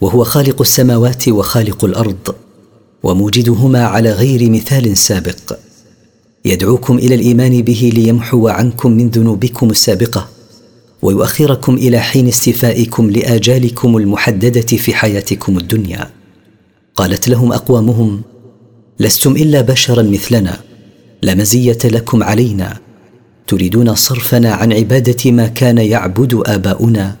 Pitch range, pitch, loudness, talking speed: 110-125 Hz, 115 Hz, -11 LUFS, 105 wpm